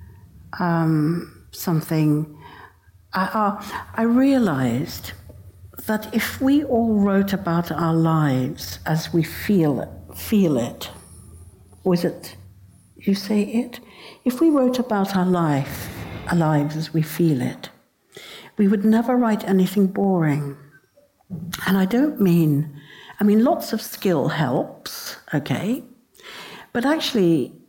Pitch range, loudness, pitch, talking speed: 140-215 Hz, -21 LUFS, 170 Hz, 120 wpm